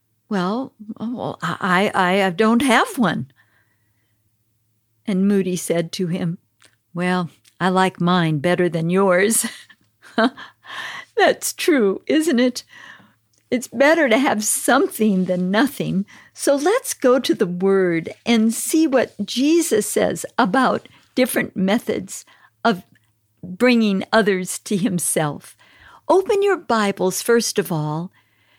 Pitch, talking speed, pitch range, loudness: 195 Hz, 120 wpm, 175-245 Hz, -19 LUFS